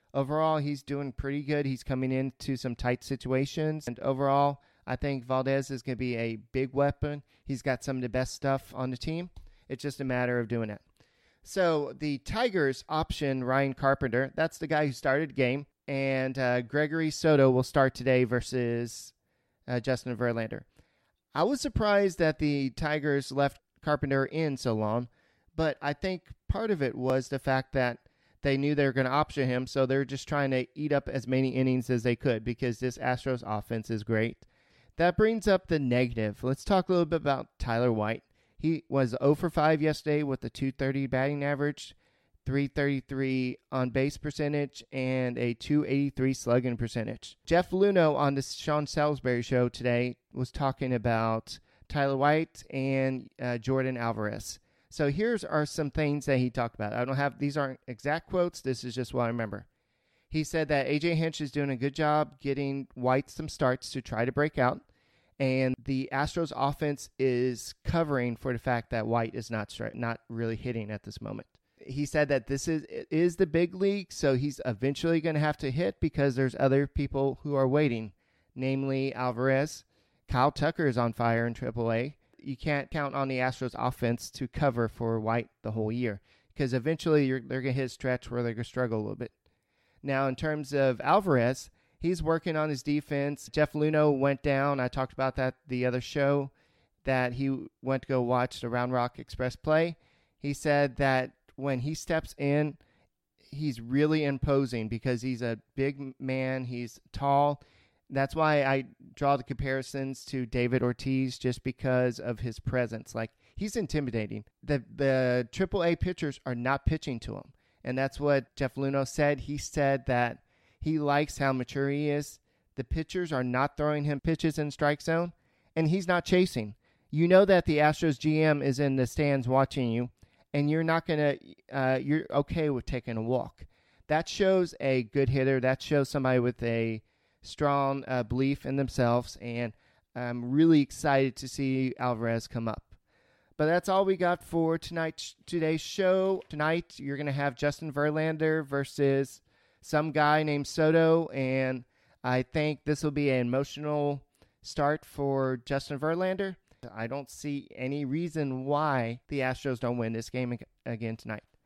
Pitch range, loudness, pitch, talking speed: 125-150 Hz, -30 LUFS, 135 Hz, 180 wpm